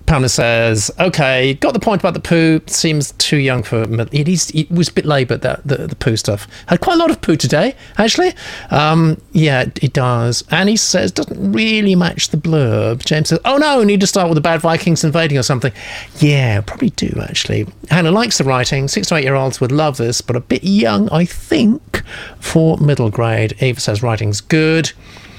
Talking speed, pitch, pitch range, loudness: 195 wpm, 155 Hz, 125-175 Hz, -14 LUFS